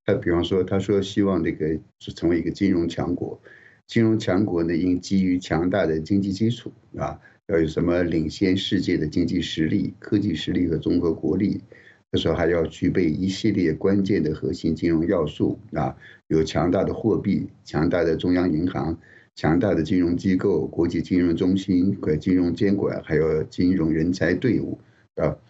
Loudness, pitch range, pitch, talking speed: -23 LUFS, 85-95 Hz, 90 Hz, 275 characters per minute